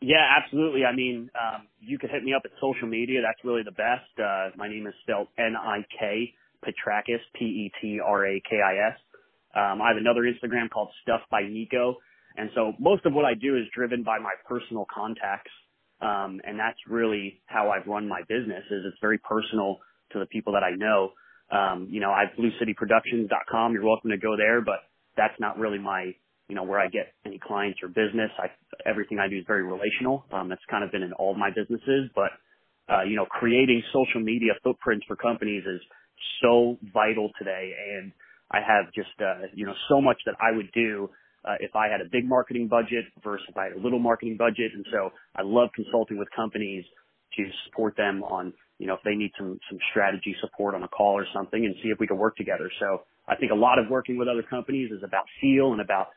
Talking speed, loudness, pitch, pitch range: 220 wpm, -26 LUFS, 110 Hz, 100-120 Hz